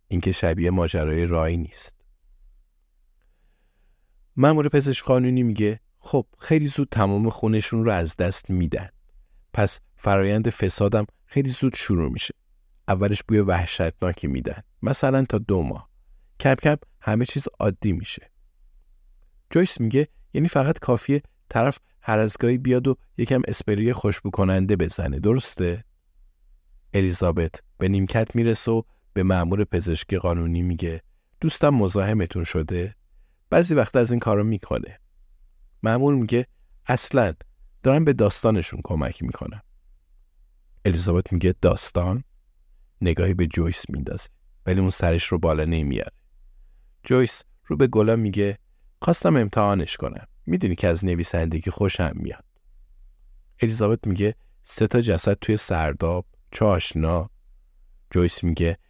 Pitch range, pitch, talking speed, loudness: 85-110 Hz, 95 Hz, 120 wpm, -23 LUFS